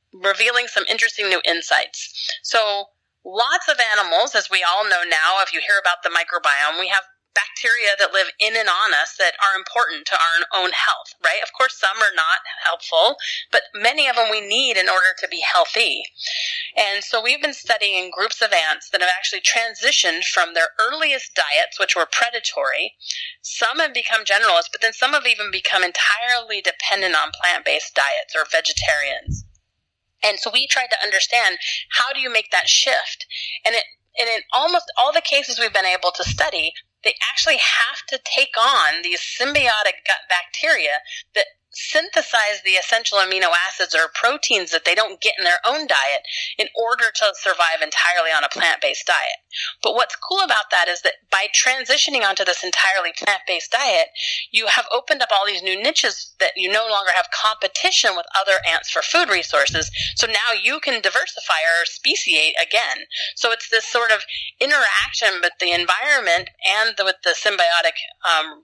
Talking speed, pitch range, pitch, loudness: 180 wpm, 195-315 Hz, 230 Hz, -18 LUFS